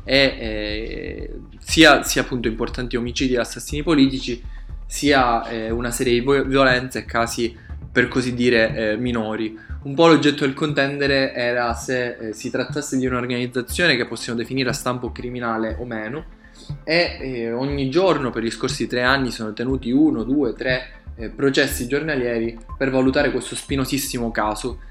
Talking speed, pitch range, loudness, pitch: 155 wpm, 115-135 Hz, -20 LUFS, 125 Hz